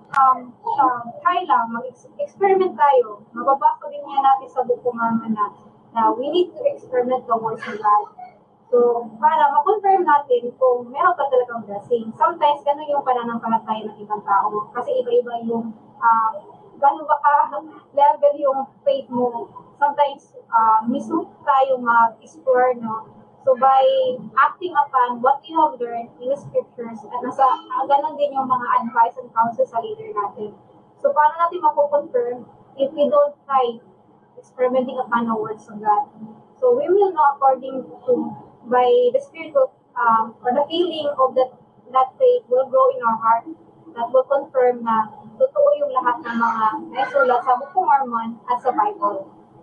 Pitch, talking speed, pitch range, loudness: 260 Hz, 160 wpm, 235-290 Hz, -20 LUFS